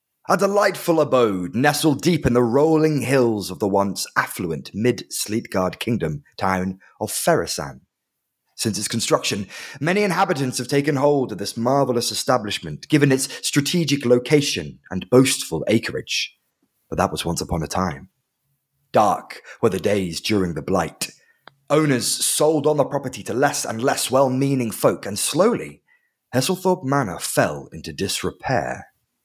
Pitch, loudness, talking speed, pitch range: 130 Hz, -21 LUFS, 145 wpm, 105-145 Hz